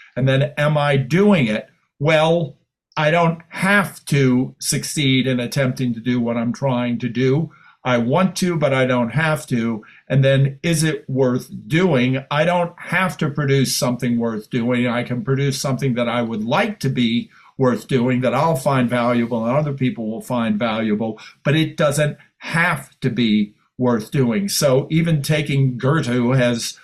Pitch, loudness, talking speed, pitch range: 135 Hz, -19 LUFS, 175 wpm, 120-155 Hz